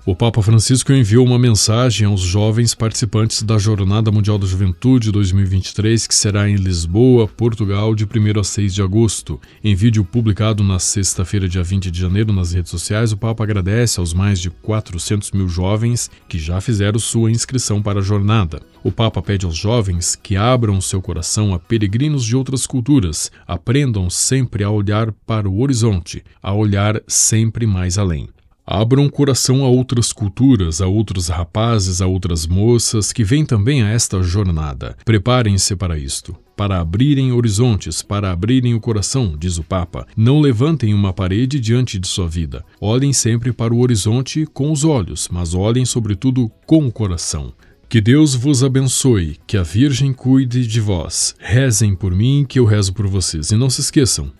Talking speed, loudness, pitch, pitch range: 170 wpm, -16 LUFS, 105 Hz, 95-120 Hz